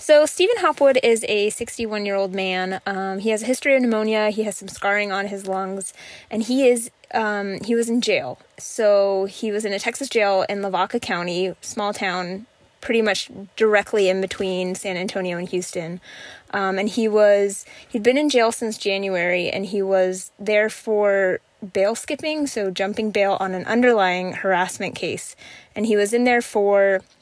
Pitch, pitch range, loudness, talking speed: 205 Hz, 190-230 Hz, -21 LUFS, 185 wpm